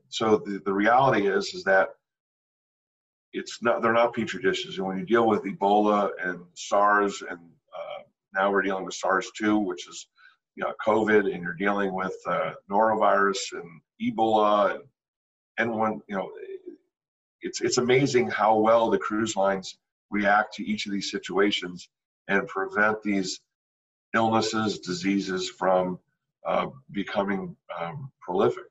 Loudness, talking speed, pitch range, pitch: -25 LUFS, 145 wpm, 95-110 Hz, 105 Hz